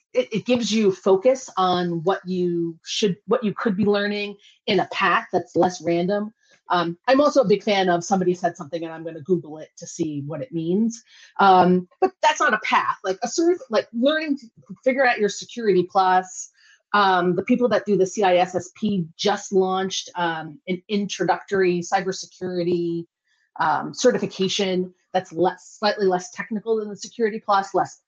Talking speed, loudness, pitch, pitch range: 175 wpm, -22 LUFS, 190 Hz, 180-210 Hz